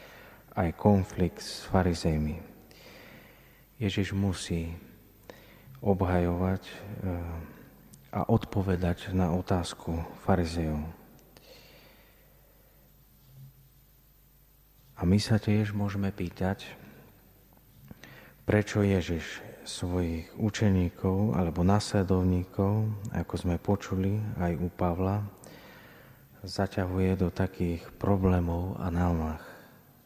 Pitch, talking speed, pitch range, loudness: 95 Hz, 70 wpm, 85-100 Hz, -30 LUFS